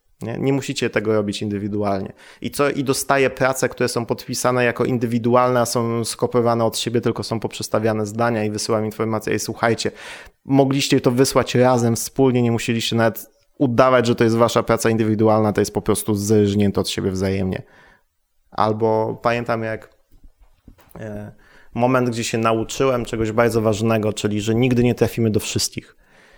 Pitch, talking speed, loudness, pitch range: 115 Hz, 160 wpm, -19 LUFS, 110-125 Hz